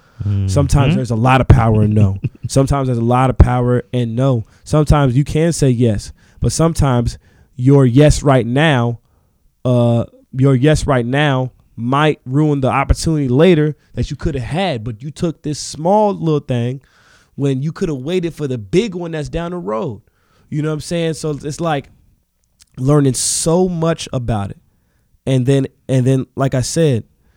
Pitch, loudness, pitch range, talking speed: 135 Hz, -16 LUFS, 120-150 Hz, 180 wpm